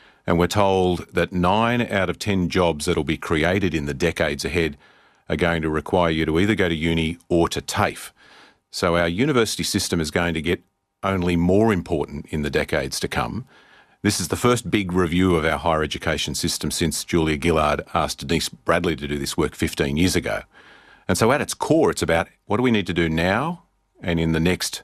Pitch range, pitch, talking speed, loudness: 80-95 Hz, 85 Hz, 210 wpm, -22 LUFS